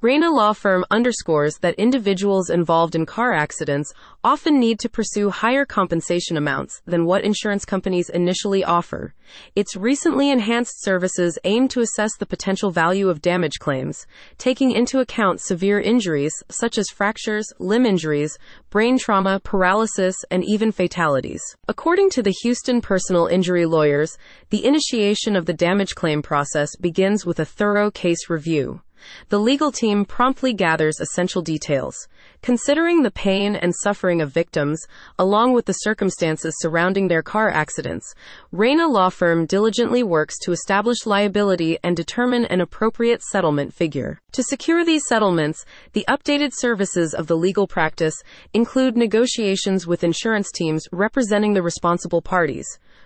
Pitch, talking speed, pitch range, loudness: 195 Hz, 145 wpm, 170-230 Hz, -20 LUFS